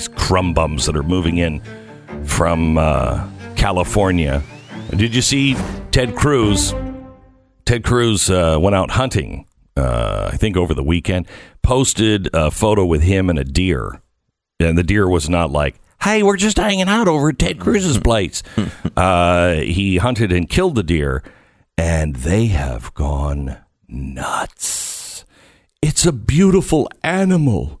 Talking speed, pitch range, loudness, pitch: 145 wpm, 80-115 Hz, -17 LUFS, 90 Hz